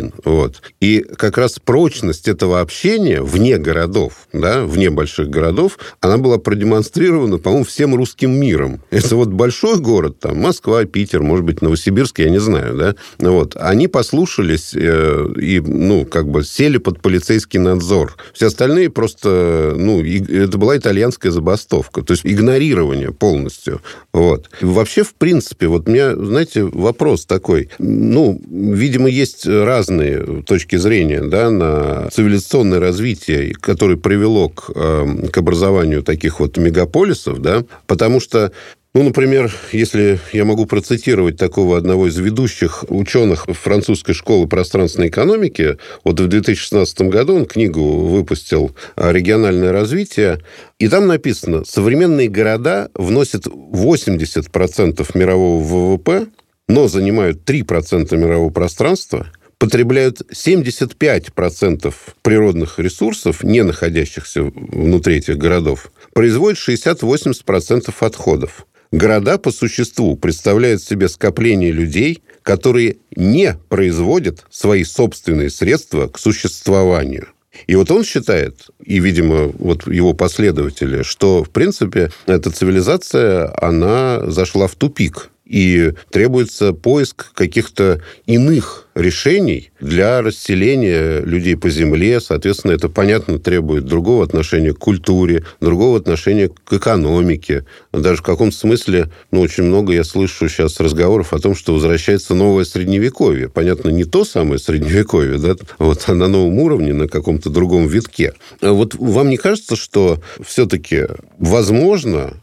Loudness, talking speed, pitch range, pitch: -14 LUFS, 125 wpm, 85-110 Hz, 95 Hz